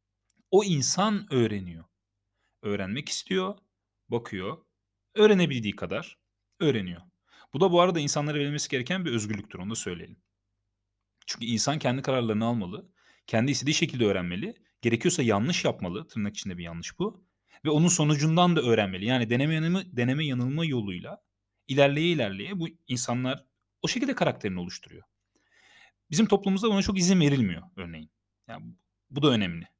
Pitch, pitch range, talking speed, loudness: 125 Hz, 100-160 Hz, 135 wpm, -27 LUFS